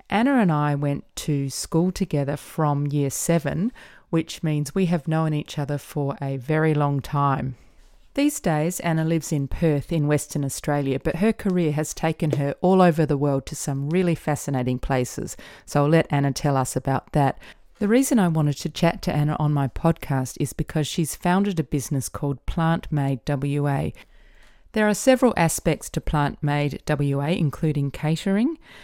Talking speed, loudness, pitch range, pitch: 175 wpm, -23 LUFS, 140-170 Hz, 150 Hz